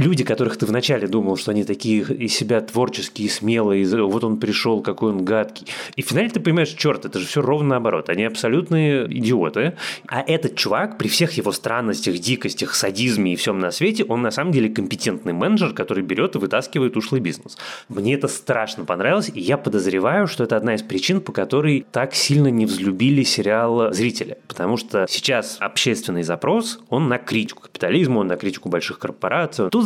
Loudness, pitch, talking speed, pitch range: -20 LUFS, 115 Hz, 185 wpm, 105-140 Hz